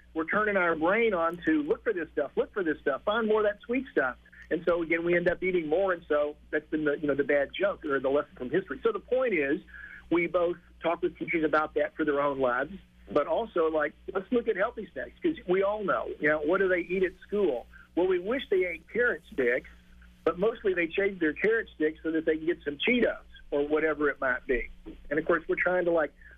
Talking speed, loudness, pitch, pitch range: 255 wpm, -29 LUFS, 170 Hz, 155-200 Hz